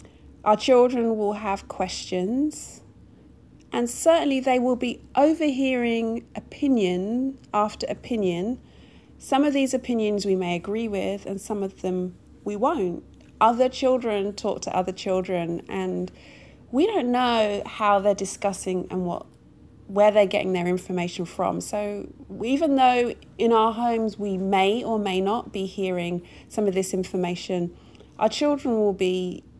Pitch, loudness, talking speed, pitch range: 210 Hz, -24 LUFS, 140 wpm, 190-245 Hz